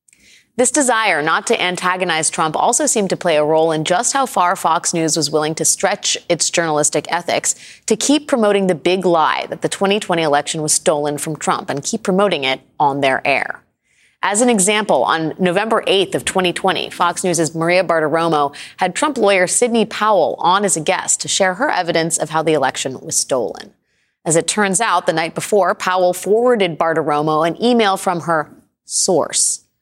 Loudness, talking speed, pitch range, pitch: -16 LUFS, 185 wpm, 160-205 Hz, 180 Hz